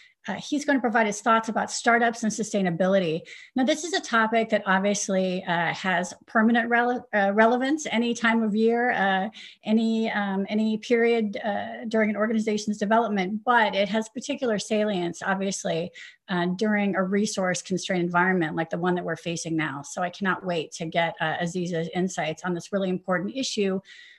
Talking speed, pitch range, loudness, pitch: 175 wpm, 180-230 Hz, -25 LUFS, 210 Hz